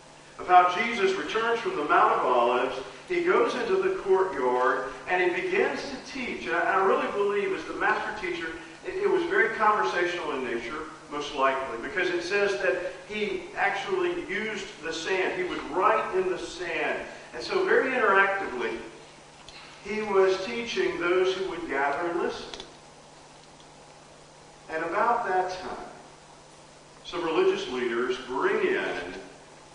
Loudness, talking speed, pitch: -26 LUFS, 145 wpm, 235 Hz